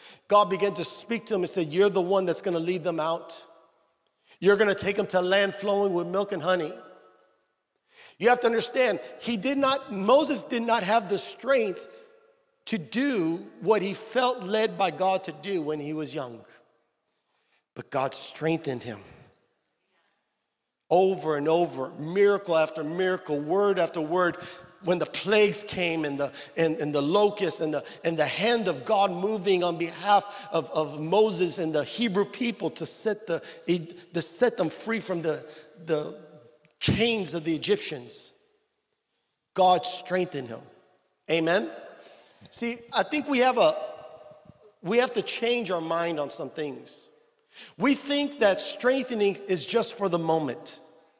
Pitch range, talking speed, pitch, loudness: 160-225 Hz, 160 wpm, 185 Hz, -26 LUFS